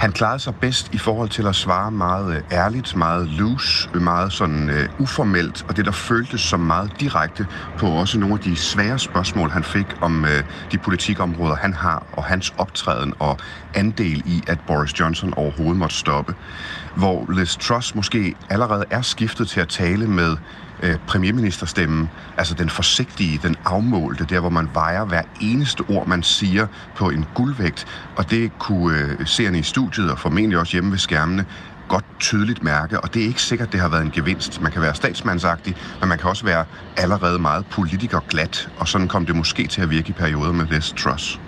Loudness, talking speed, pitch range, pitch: -20 LUFS, 190 wpm, 80-105 Hz, 90 Hz